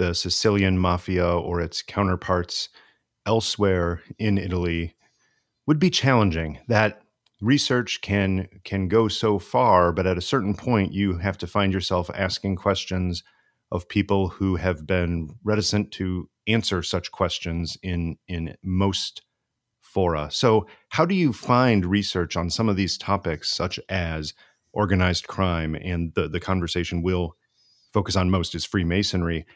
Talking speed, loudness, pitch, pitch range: 140 wpm, -24 LUFS, 95 Hz, 85-105 Hz